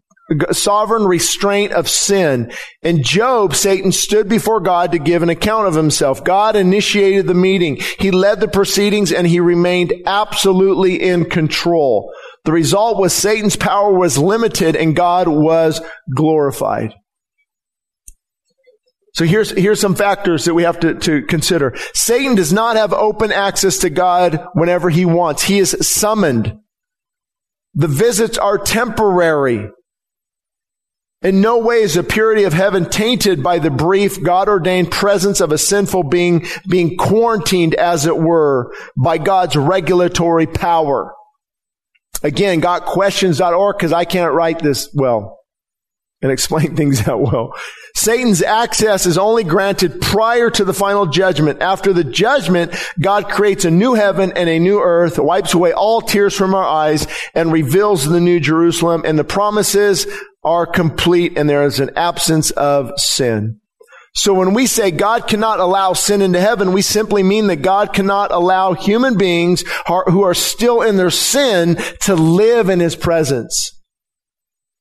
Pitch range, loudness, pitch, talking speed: 170-205 Hz, -14 LUFS, 185 Hz, 150 wpm